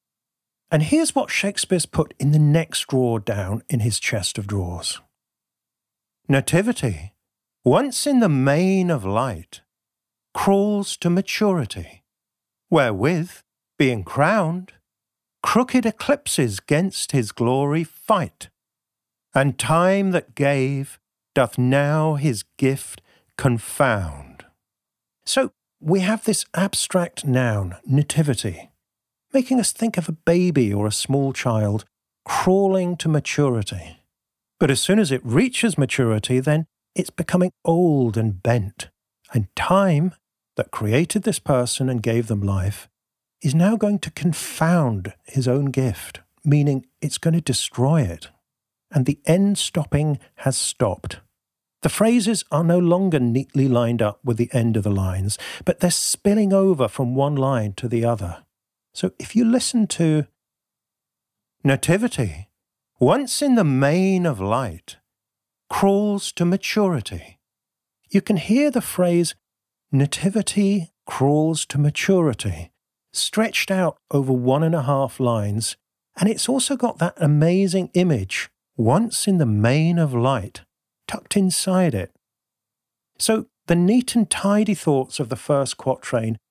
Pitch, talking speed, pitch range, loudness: 145 Hz, 130 wpm, 115-185 Hz, -21 LUFS